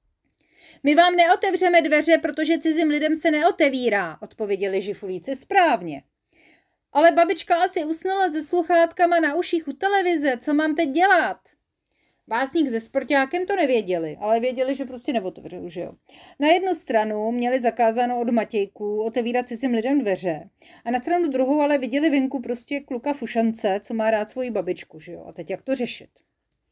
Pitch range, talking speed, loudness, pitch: 230-335 Hz, 160 wpm, -22 LUFS, 280 Hz